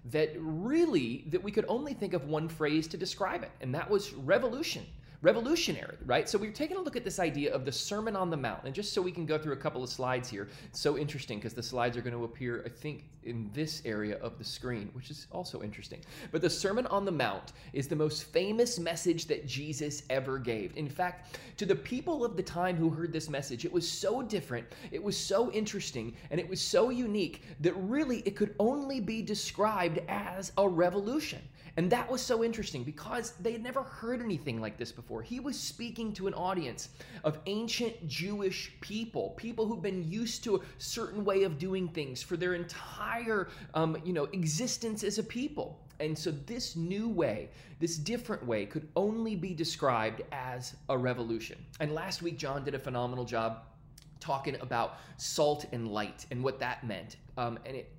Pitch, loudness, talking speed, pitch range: 165 Hz, -34 LUFS, 205 wpm, 135-205 Hz